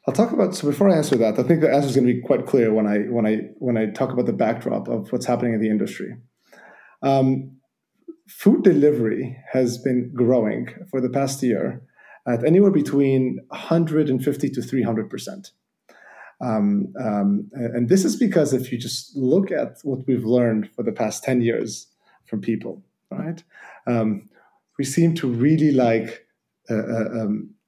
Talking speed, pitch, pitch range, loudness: 175 wpm, 130 Hz, 115-150 Hz, -21 LUFS